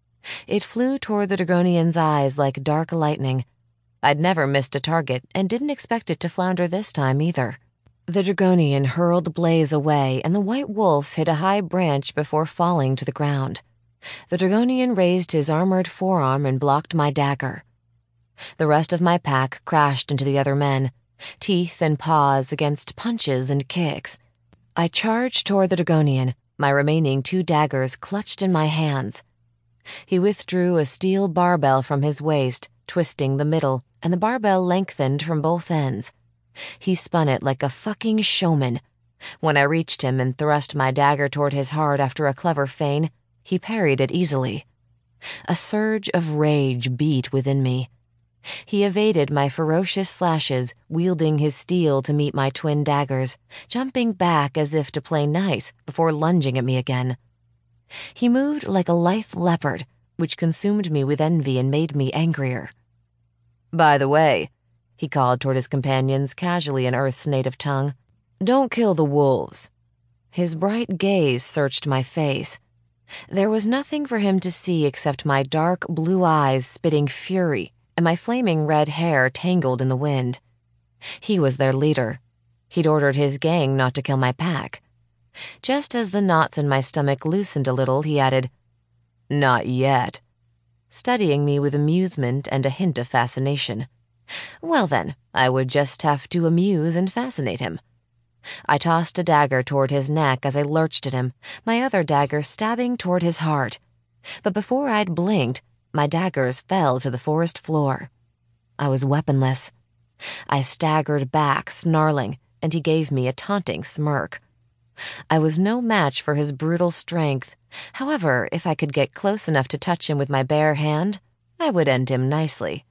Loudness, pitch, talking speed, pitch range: -21 LUFS, 145 Hz, 165 wpm, 130-175 Hz